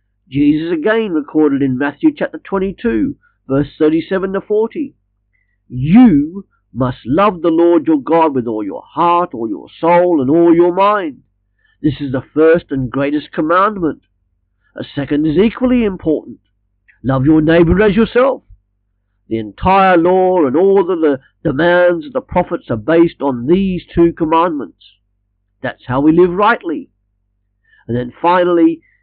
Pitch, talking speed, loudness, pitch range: 160 Hz, 145 wpm, -13 LUFS, 125-190 Hz